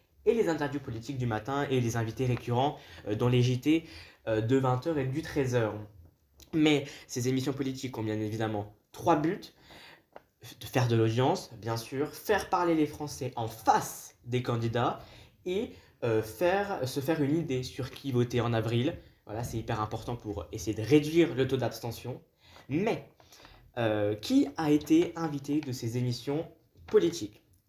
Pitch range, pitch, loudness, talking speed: 115-145 Hz, 125 Hz, -30 LUFS, 165 wpm